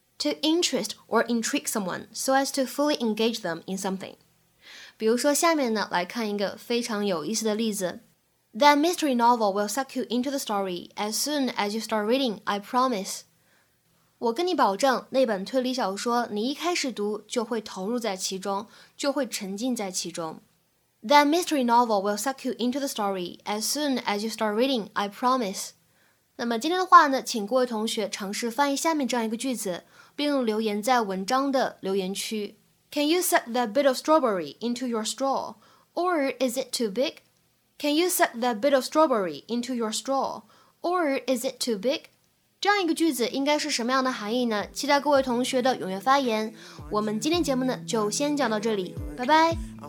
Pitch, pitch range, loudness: 240 Hz, 210-275 Hz, -26 LUFS